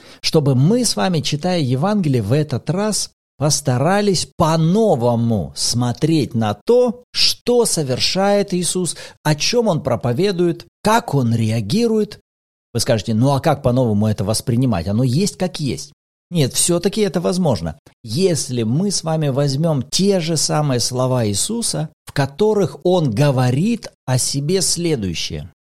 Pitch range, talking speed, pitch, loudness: 125-185 Hz, 140 wpm, 150 Hz, -18 LUFS